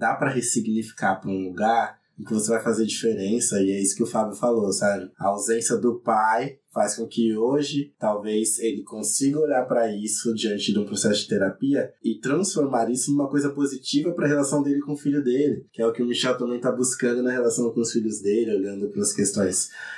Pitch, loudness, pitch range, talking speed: 115 Hz, -24 LUFS, 110-140 Hz, 220 wpm